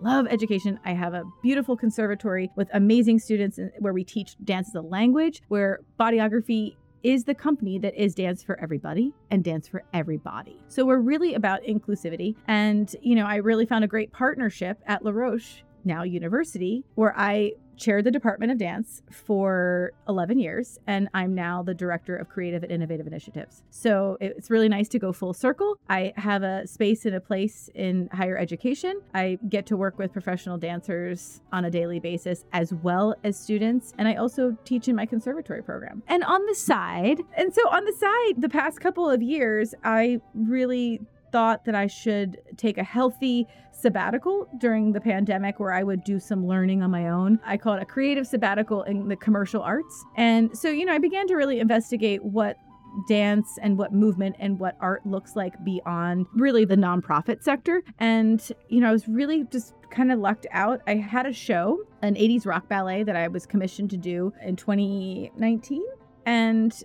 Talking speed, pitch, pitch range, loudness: 190 wpm, 210 Hz, 190-240 Hz, -25 LUFS